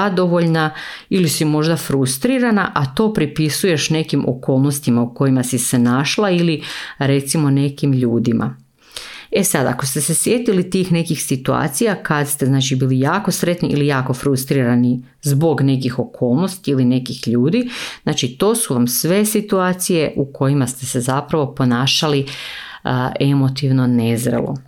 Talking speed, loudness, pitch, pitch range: 140 wpm, -17 LUFS, 140 Hz, 130-165 Hz